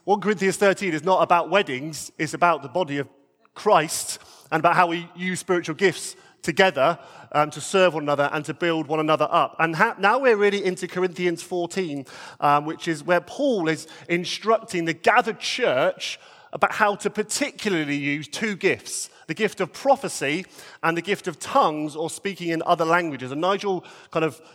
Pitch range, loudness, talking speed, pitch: 160-195 Hz, -23 LUFS, 185 wpm, 175 Hz